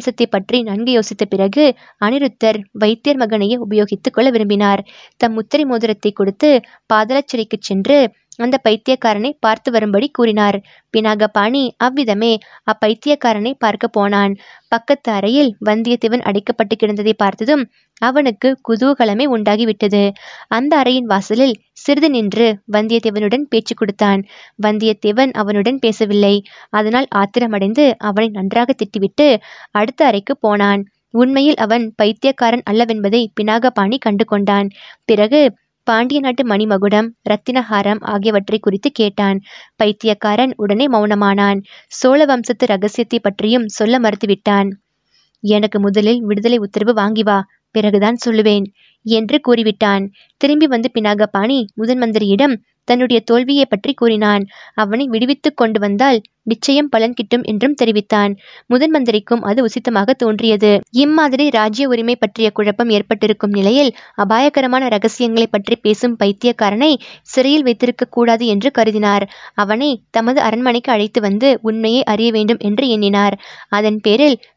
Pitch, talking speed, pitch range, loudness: 225 Hz, 110 wpm, 210-245 Hz, -14 LUFS